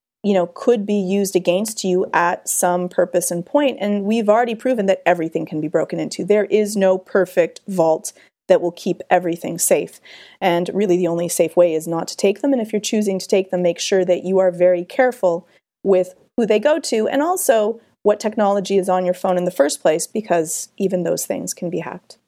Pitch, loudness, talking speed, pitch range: 190 Hz, -19 LUFS, 220 wpm, 175-210 Hz